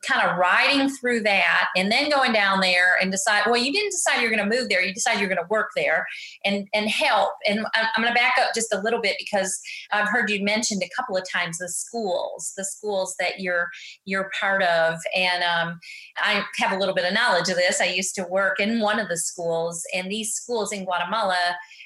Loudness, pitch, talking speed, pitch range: -22 LUFS, 200 Hz, 230 wpm, 180-225 Hz